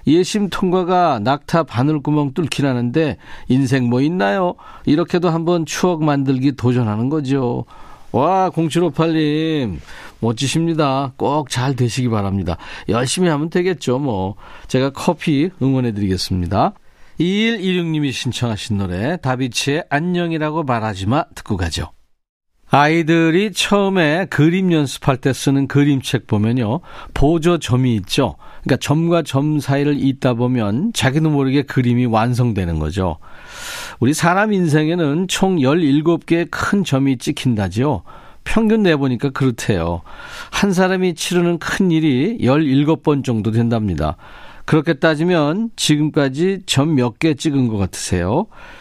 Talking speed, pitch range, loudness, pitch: 280 characters per minute, 125-165 Hz, -17 LUFS, 140 Hz